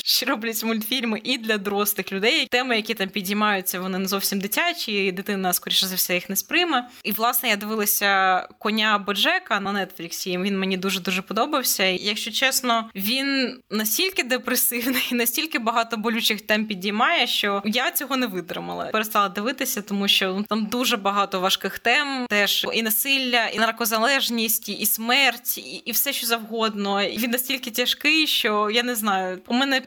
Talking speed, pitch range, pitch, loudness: 165 wpm, 200-250 Hz, 225 Hz, -22 LUFS